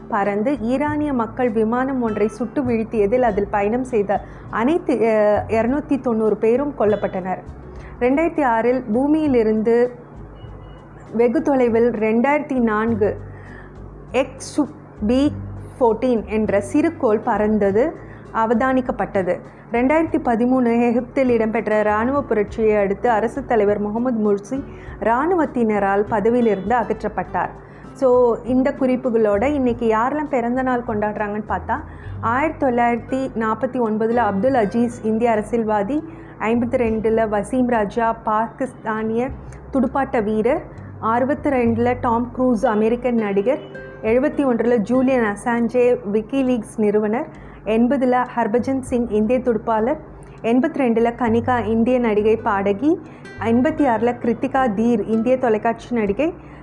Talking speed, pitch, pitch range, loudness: 105 wpm, 235 Hz, 215-255 Hz, -19 LUFS